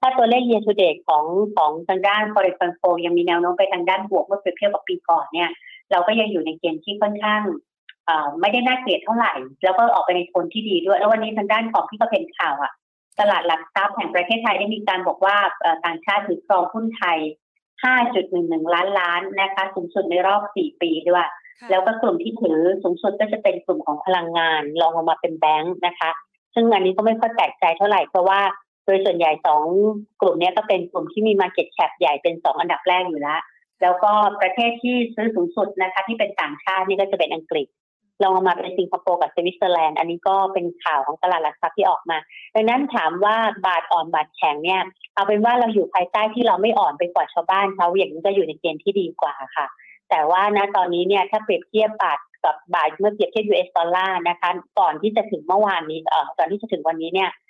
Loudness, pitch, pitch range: -20 LUFS, 190 Hz, 175-210 Hz